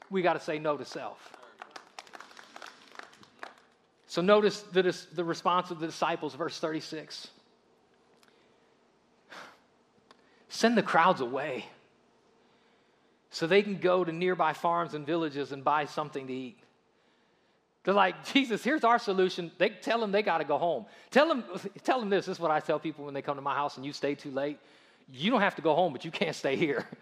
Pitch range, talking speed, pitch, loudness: 150-195 Hz, 180 wpm, 170 Hz, -29 LUFS